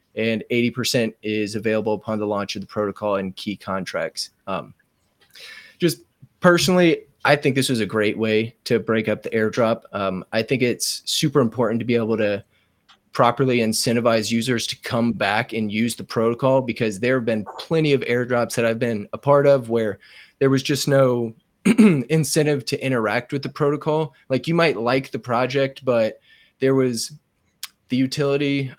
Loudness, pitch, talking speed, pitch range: -21 LUFS, 120 Hz, 175 wpm, 110-140 Hz